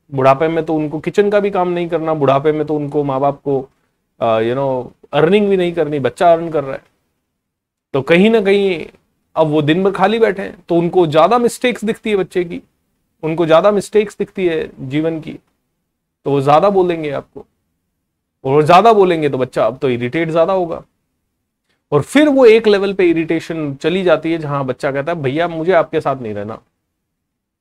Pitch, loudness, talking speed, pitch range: 160 Hz, -15 LUFS, 200 wpm, 140-185 Hz